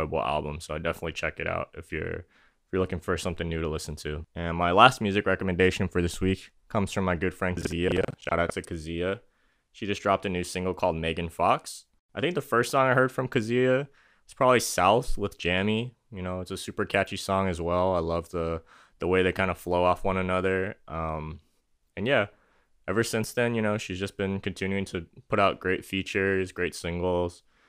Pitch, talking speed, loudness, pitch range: 95 Hz, 215 wpm, -27 LUFS, 85-100 Hz